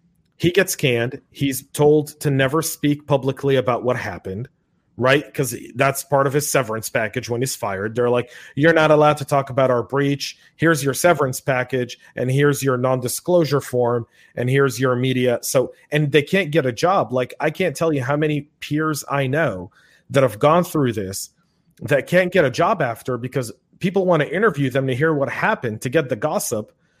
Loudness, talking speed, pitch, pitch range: -20 LUFS, 200 wpm, 140 Hz, 125-155 Hz